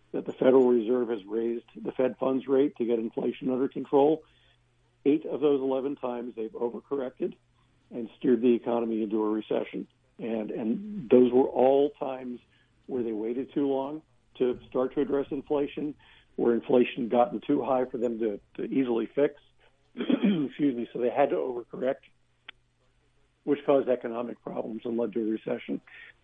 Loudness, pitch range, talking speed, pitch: -28 LUFS, 120-140 Hz, 165 wpm, 125 Hz